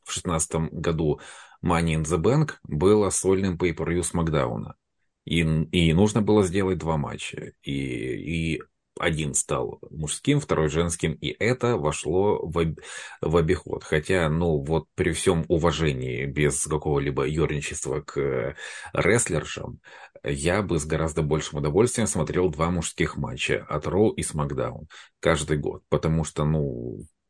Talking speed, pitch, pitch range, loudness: 135 wpm, 80 Hz, 75-85 Hz, -25 LUFS